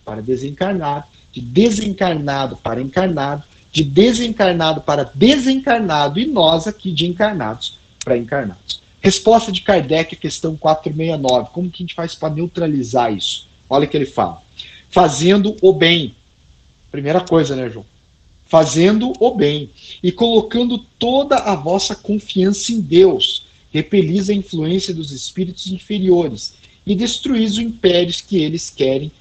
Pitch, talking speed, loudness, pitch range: 170 Hz, 135 wpm, -16 LUFS, 140-200 Hz